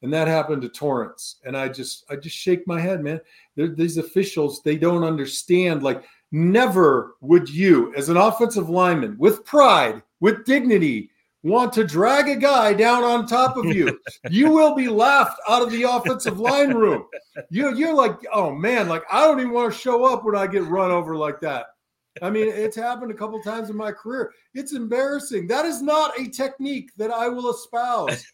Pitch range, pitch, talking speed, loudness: 170-250 Hz, 220 Hz, 195 wpm, -20 LUFS